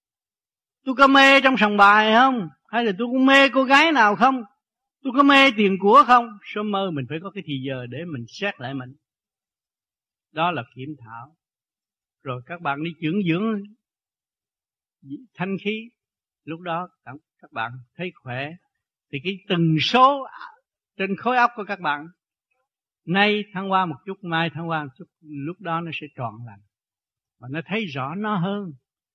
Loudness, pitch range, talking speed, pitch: -20 LUFS, 145-225 Hz, 175 wpm, 185 Hz